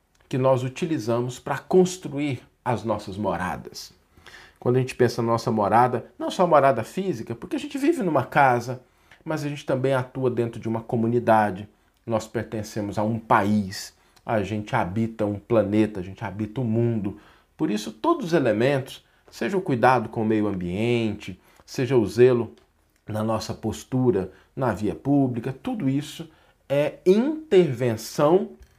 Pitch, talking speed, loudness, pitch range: 120 Hz, 155 wpm, -24 LUFS, 110-135 Hz